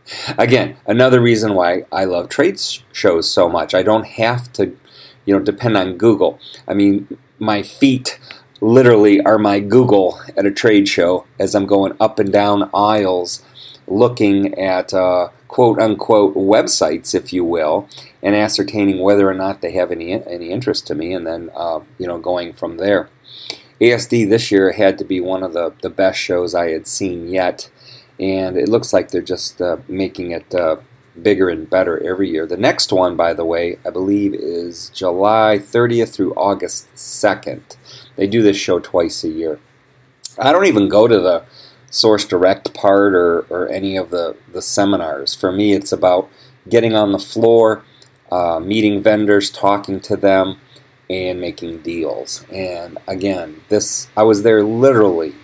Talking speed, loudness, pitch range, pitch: 170 wpm, -15 LUFS, 95-110 Hz, 100 Hz